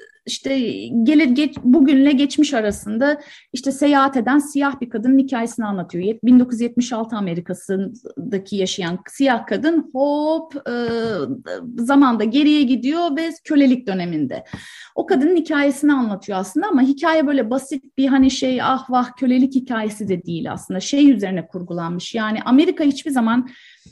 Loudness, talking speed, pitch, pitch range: -18 LUFS, 135 wpm, 260 Hz, 220-285 Hz